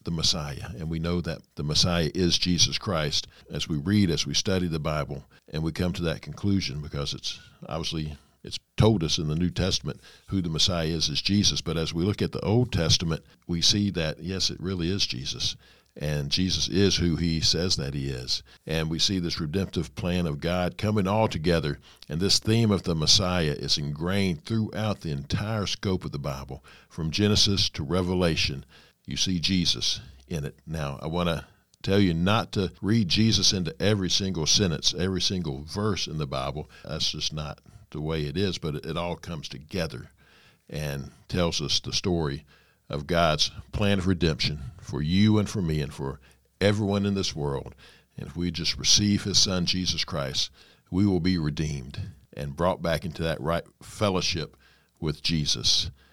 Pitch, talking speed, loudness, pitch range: 85 Hz, 190 wpm, -26 LUFS, 75-95 Hz